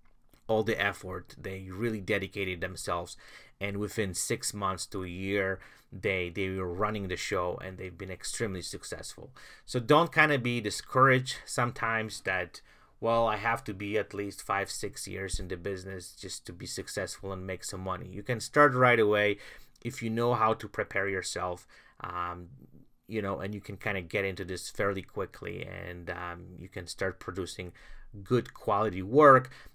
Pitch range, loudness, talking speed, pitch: 95-115 Hz, -30 LUFS, 180 wpm, 100 Hz